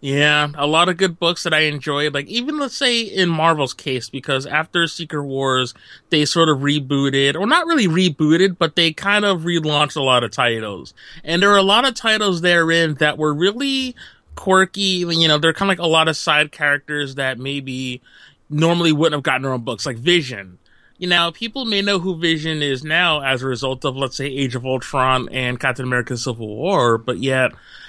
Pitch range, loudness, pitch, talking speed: 135-175 Hz, -17 LUFS, 150 Hz, 205 wpm